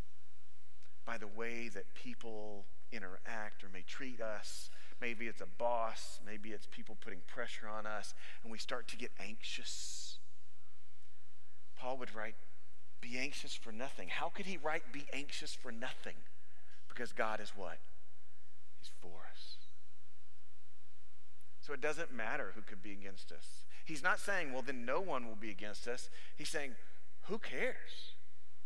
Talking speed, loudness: 155 wpm, -44 LUFS